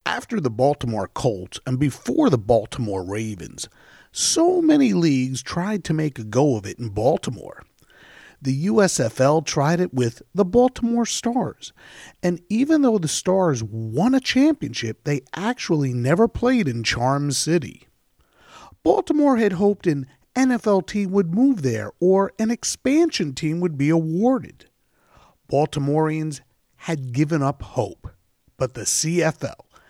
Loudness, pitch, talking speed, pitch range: -21 LUFS, 155 Hz, 135 wpm, 130-210 Hz